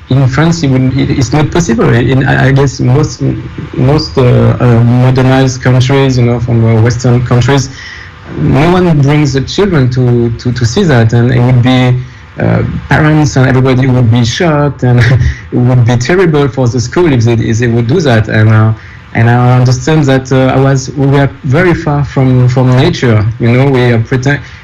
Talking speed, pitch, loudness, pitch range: 190 wpm, 130 Hz, -8 LUFS, 120-140 Hz